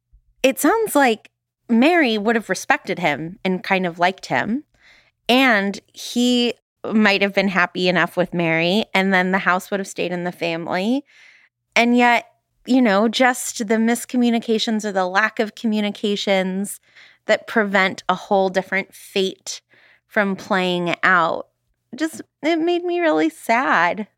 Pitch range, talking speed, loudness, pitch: 185-240 Hz, 145 wpm, -19 LUFS, 205 Hz